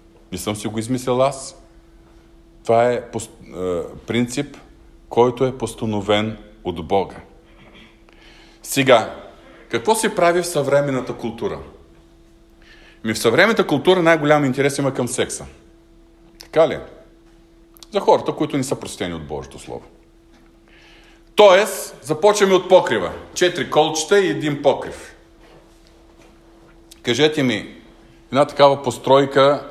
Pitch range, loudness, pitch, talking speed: 110-160 Hz, -18 LUFS, 135 Hz, 110 wpm